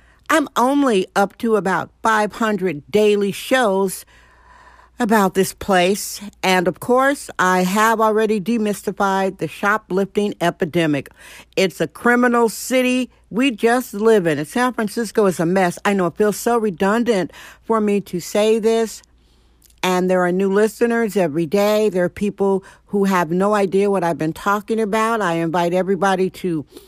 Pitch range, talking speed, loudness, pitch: 185-225 Hz, 155 wpm, -18 LUFS, 200 Hz